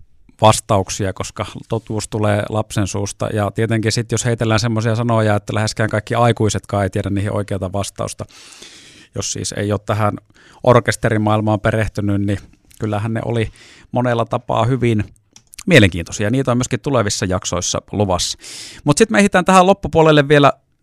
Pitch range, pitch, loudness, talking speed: 105-120 Hz, 110 Hz, -17 LUFS, 145 wpm